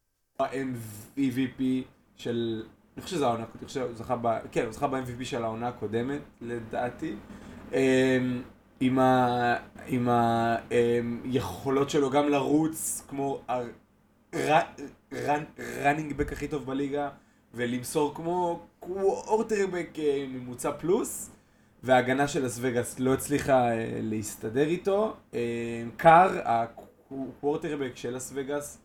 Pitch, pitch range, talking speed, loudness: 130 Hz, 120-145 Hz, 100 wpm, -28 LUFS